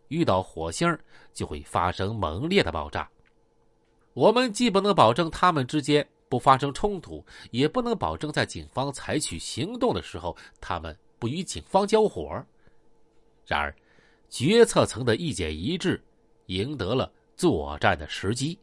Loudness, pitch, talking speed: -26 LUFS, 140 Hz, 230 characters per minute